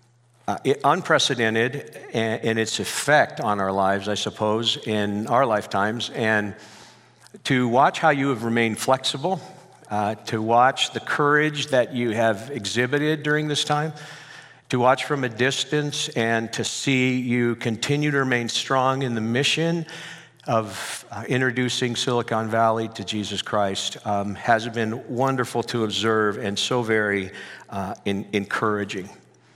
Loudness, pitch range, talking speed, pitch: -23 LUFS, 110-135 Hz, 145 wpm, 120 Hz